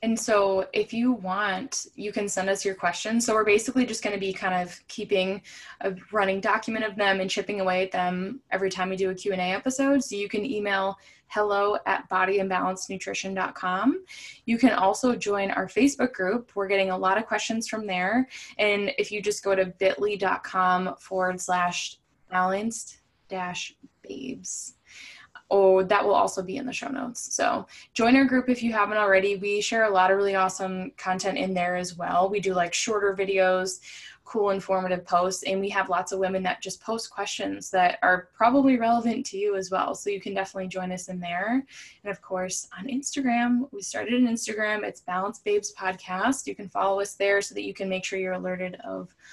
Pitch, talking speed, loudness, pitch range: 195 Hz, 200 wpm, -26 LUFS, 185-220 Hz